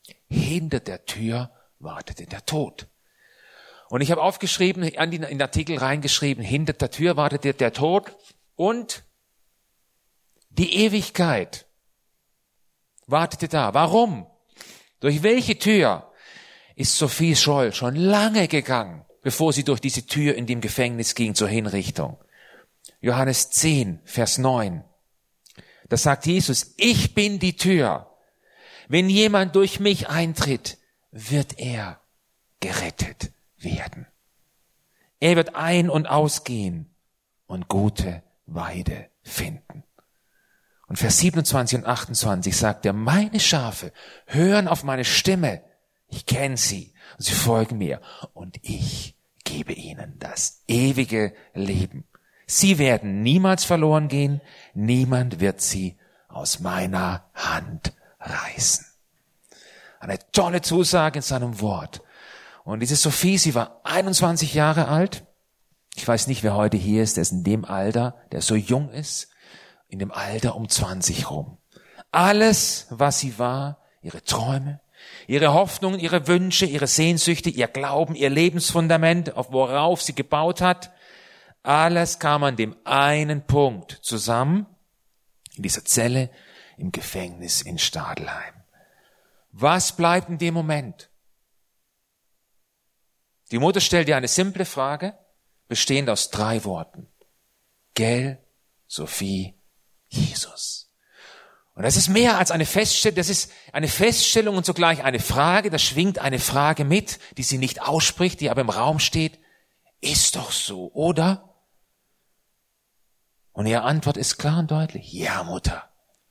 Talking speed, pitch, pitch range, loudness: 125 wpm, 145 Hz, 120-170 Hz, -22 LUFS